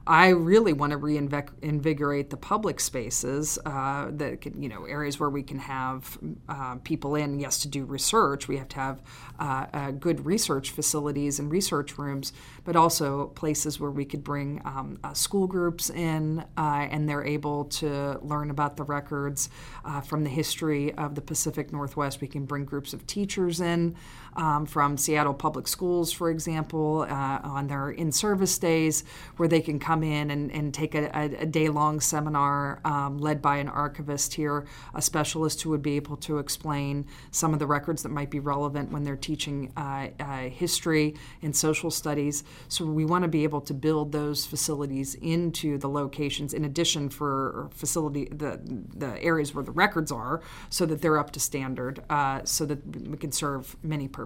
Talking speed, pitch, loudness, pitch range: 185 wpm, 145 Hz, -28 LUFS, 140-155 Hz